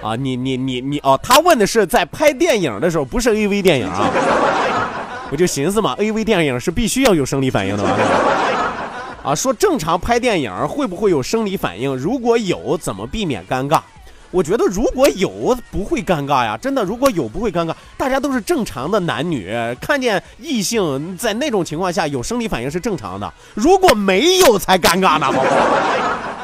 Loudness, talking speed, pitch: -17 LUFS, 285 characters per minute, 200 Hz